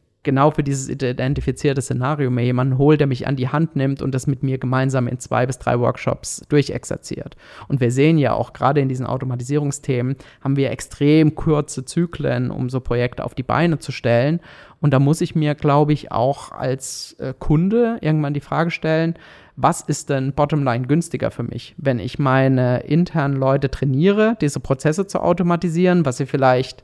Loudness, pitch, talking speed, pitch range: -19 LUFS, 140 Hz, 180 wpm, 130-150 Hz